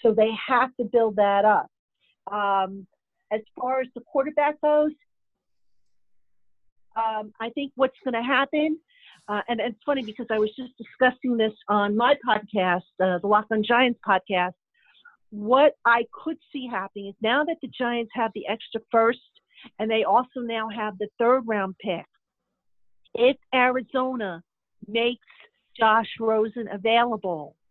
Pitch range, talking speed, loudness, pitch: 210-255 Hz, 150 wpm, -24 LUFS, 230 Hz